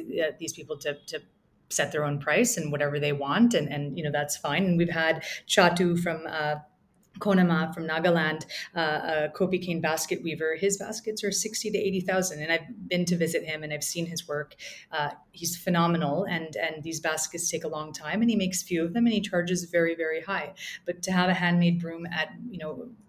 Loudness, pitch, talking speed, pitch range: -27 LUFS, 170 Hz, 215 wpm, 155-185 Hz